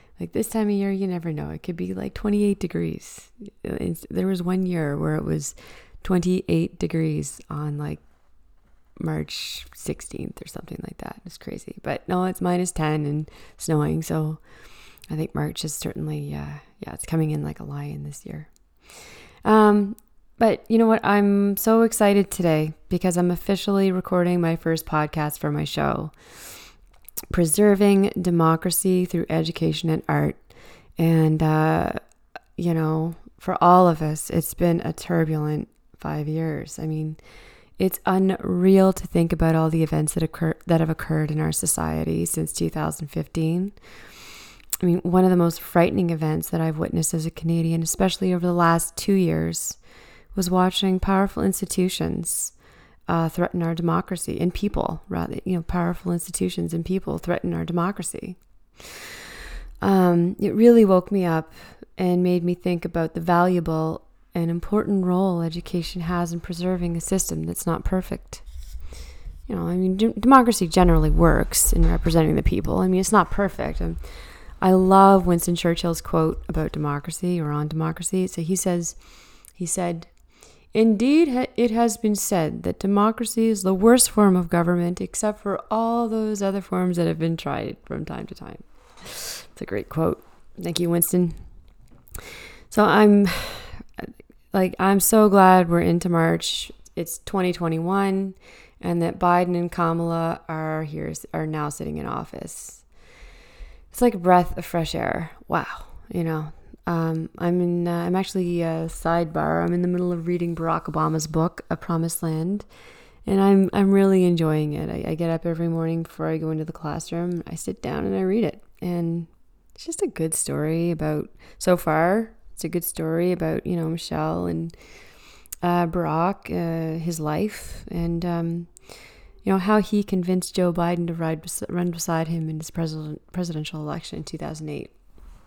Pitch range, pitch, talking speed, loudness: 160-185 Hz, 170 Hz, 165 wpm, -22 LUFS